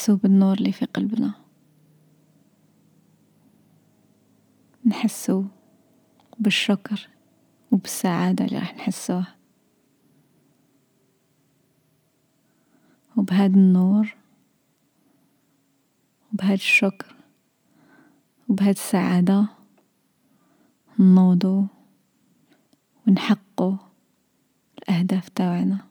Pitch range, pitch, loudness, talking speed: 180-220 Hz, 195 Hz, -21 LUFS, 50 wpm